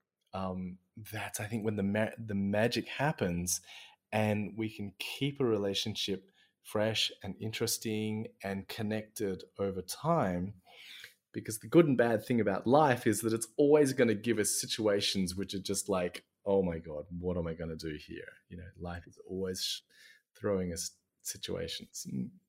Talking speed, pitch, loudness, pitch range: 170 wpm, 105 Hz, -33 LUFS, 95-110 Hz